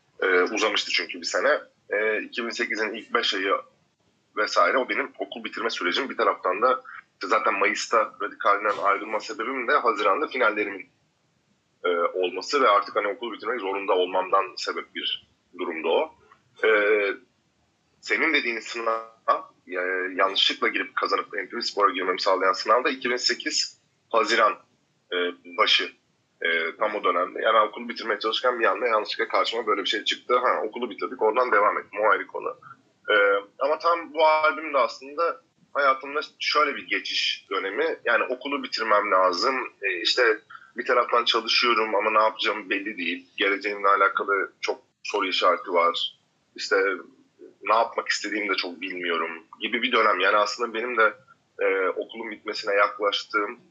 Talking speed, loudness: 145 wpm, -24 LUFS